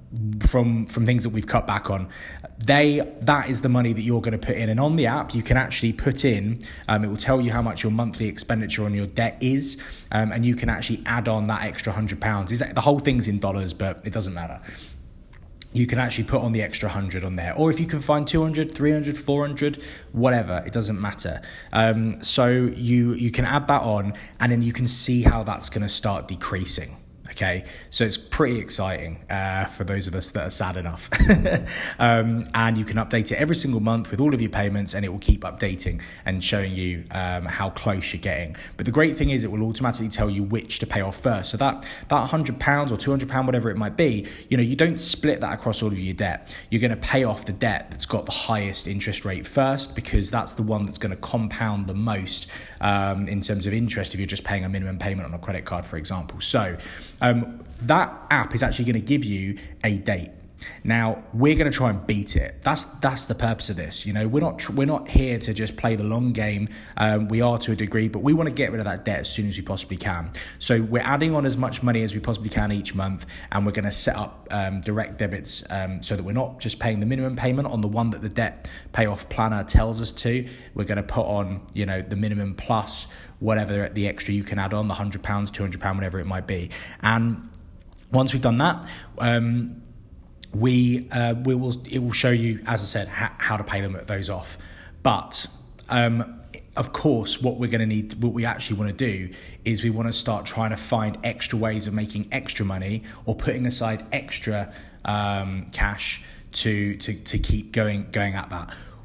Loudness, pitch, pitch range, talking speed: -24 LUFS, 110 Hz, 100-120 Hz, 240 wpm